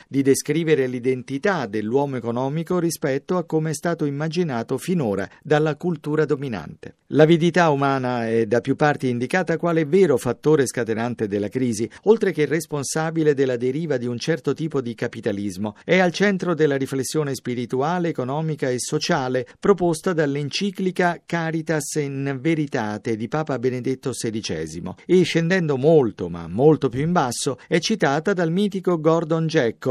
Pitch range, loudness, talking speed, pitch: 130-165 Hz, -22 LUFS, 140 wpm, 150 Hz